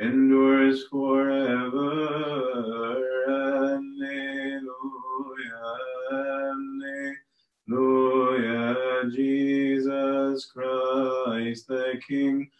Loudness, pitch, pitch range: -26 LUFS, 135 Hz, 130-135 Hz